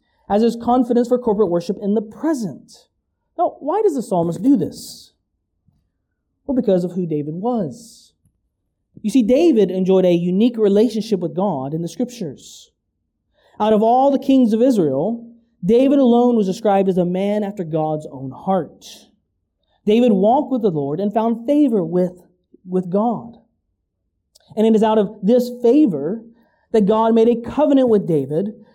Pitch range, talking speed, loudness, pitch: 185-240 Hz, 160 wpm, -17 LUFS, 215 Hz